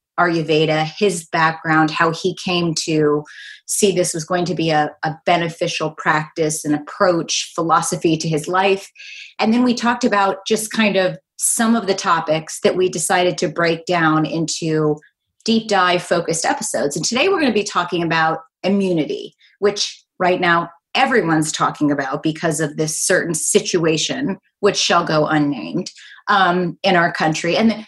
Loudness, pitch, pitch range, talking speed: -18 LUFS, 175 Hz, 160-195 Hz, 165 wpm